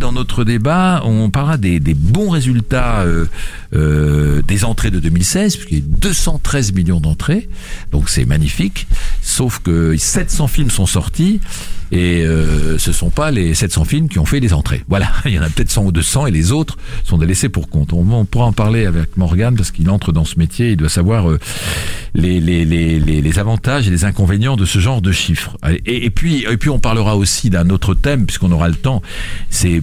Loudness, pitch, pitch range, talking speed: -15 LUFS, 95 Hz, 85-120 Hz, 210 wpm